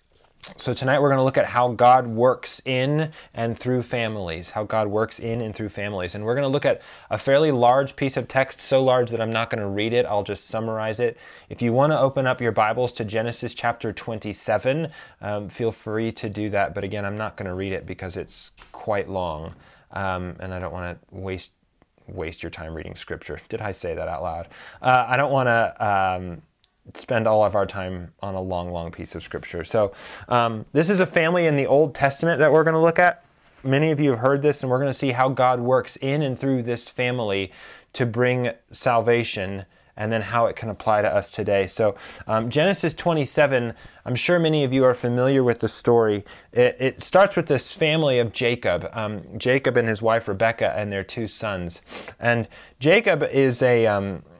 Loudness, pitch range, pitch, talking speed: -22 LUFS, 105-130 Hz, 115 Hz, 215 wpm